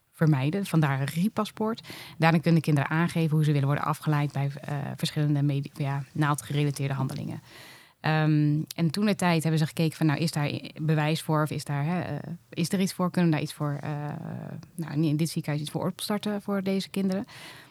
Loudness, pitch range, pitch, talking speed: -27 LUFS, 145-170 Hz, 155 Hz, 205 wpm